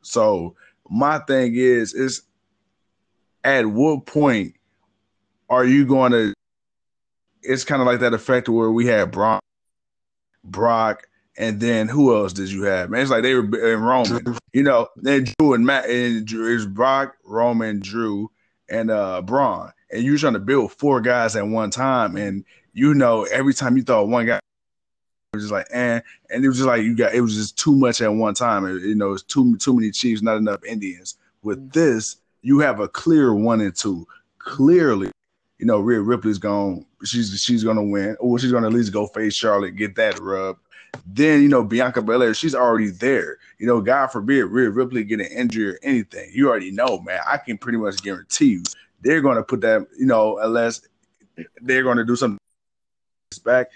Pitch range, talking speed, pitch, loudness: 105-130 Hz, 195 wpm, 115 Hz, -19 LUFS